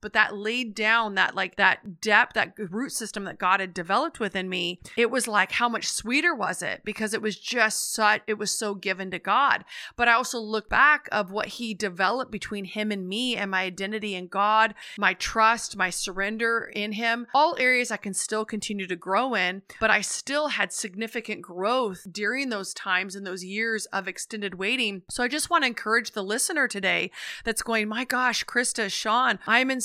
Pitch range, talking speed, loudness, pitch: 195-235 Hz, 205 wpm, -25 LUFS, 215 Hz